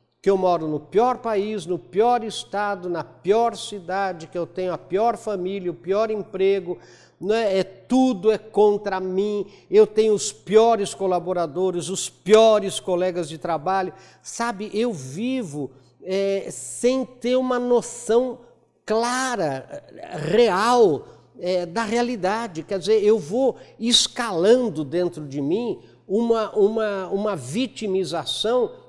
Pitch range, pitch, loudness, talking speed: 180-230 Hz, 200 Hz, -22 LUFS, 130 wpm